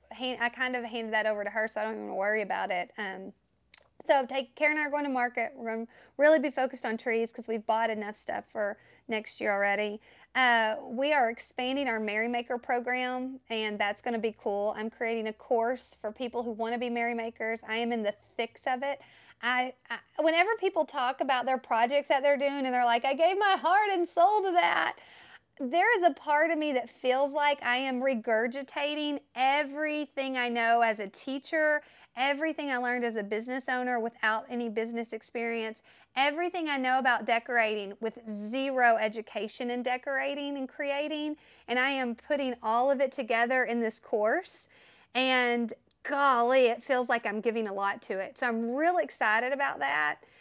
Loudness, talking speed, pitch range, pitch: -29 LUFS, 195 wpm, 225-275 Hz, 245 Hz